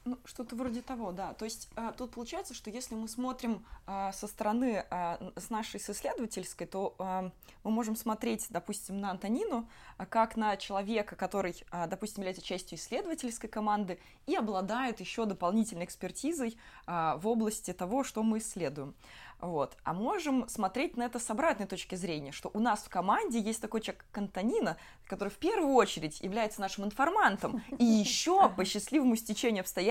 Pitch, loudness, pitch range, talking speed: 215 Hz, -34 LUFS, 190-240 Hz, 170 wpm